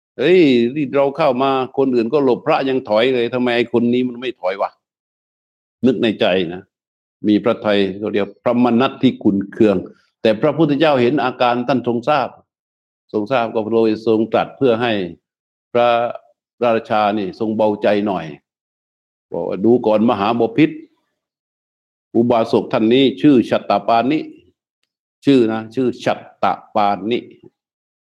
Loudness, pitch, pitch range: -17 LUFS, 120 Hz, 110-130 Hz